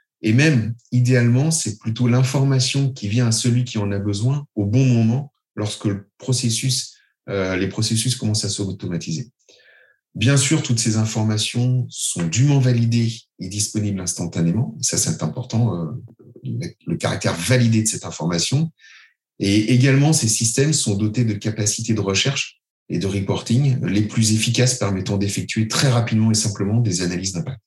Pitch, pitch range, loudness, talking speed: 115 Hz, 105-125 Hz, -20 LUFS, 155 wpm